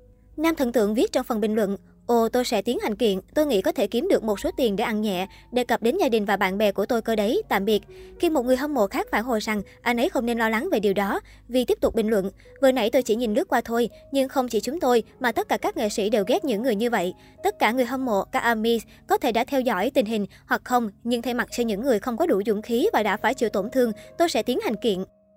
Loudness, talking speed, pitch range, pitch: -24 LUFS, 300 wpm, 210-255 Hz, 235 Hz